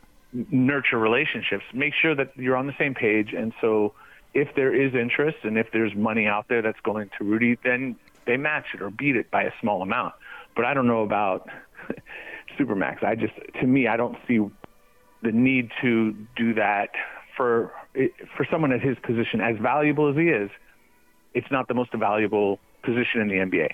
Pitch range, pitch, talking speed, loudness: 110-130 Hz, 120 Hz, 190 wpm, -24 LUFS